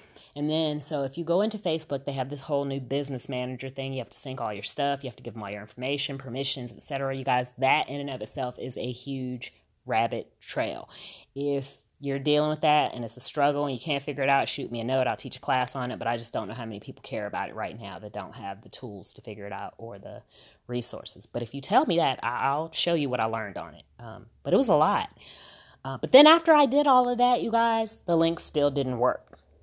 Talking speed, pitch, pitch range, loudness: 265 wpm, 135 Hz, 120-145 Hz, -27 LUFS